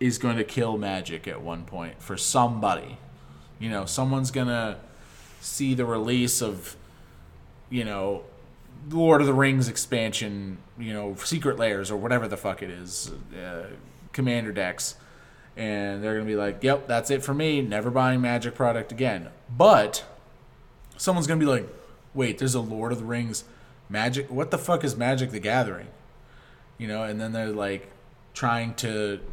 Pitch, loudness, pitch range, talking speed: 120 Hz, -26 LUFS, 105-130 Hz, 170 wpm